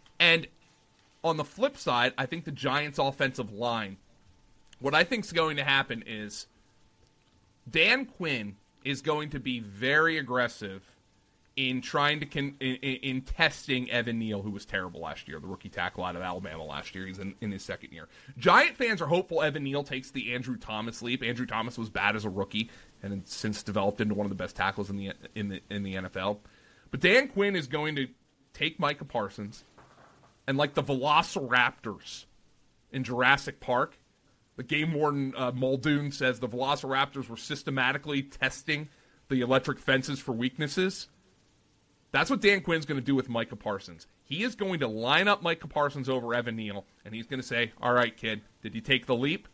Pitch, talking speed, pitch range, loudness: 130 Hz, 190 wpm, 105-145 Hz, -29 LUFS